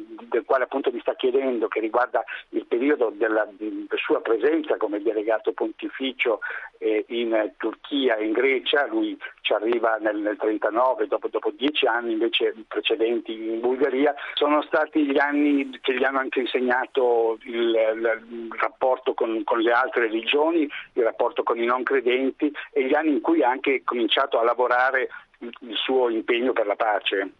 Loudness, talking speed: -23 LUFS, 165 wpm